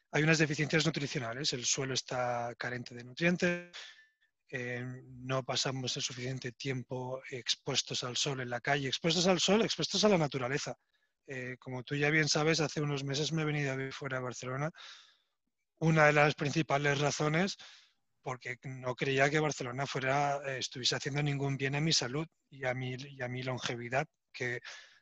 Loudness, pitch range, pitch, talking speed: -33 LUFS, 130-155 Hz, 140 Hz, 175 wpm